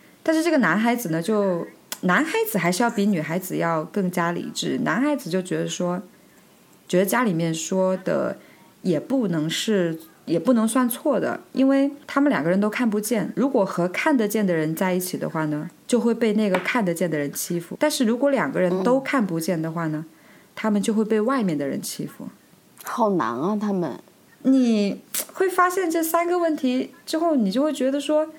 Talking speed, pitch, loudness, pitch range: 280 characters per minute, 215 Hz, -23 LUFS, 180-270 Hz